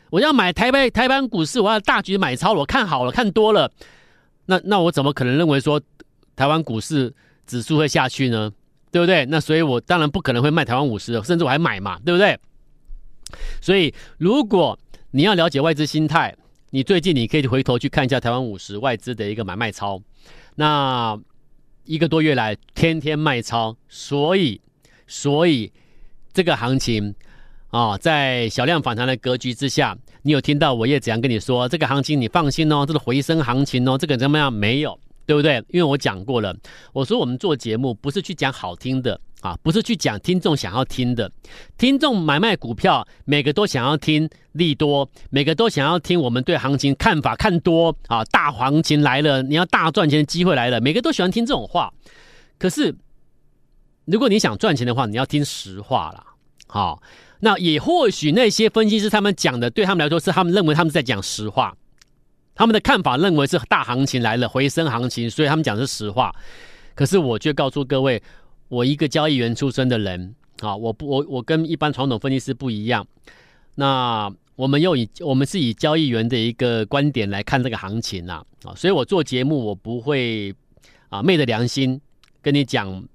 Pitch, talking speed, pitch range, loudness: 140 Hz, 295 characters per minute, 125-160 Hz, -19 LUFS